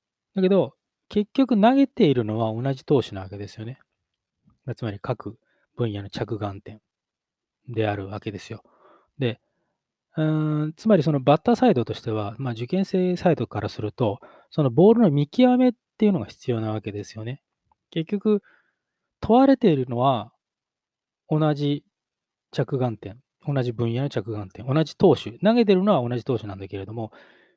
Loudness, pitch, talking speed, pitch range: -23 LUFS, 135 Hz, 305 characters per minute, 110-180 Hz